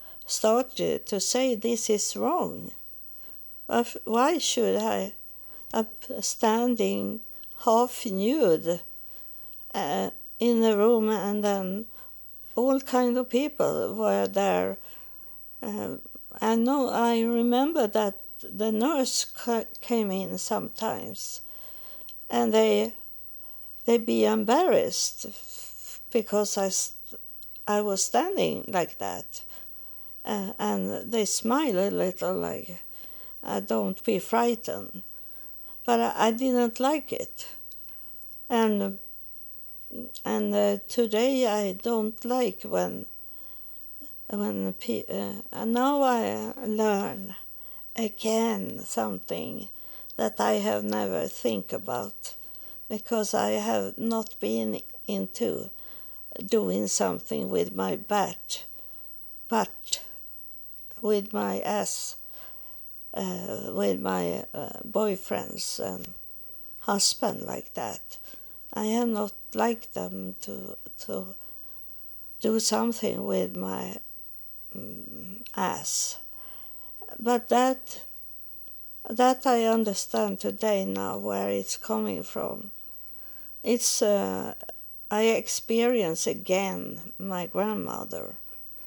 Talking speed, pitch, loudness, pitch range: 95 wpm, 220 Hz, -28 LUFS, 190-235 Hz